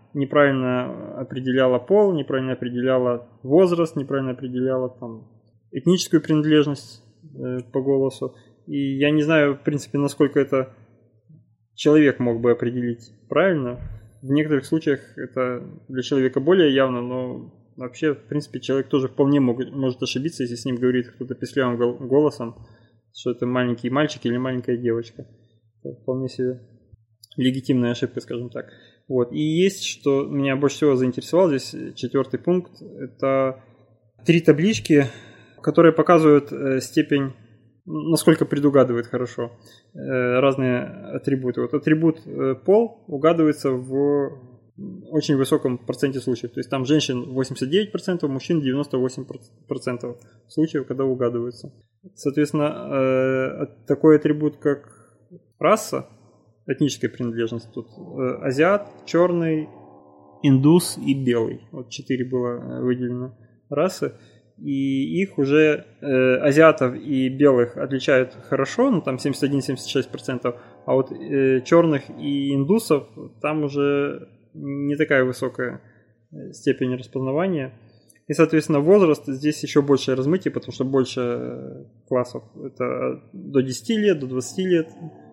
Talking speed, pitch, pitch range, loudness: 120 wpm, 135 Hz, 125-150 Hz, -21 LUFS